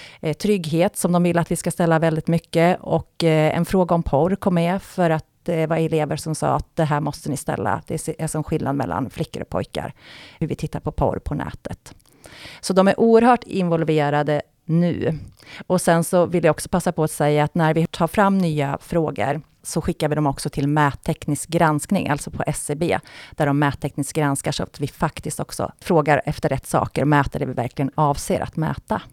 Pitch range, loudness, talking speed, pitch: 145-170 Hz, -21 LUFS, 205 wpm, 160 Hz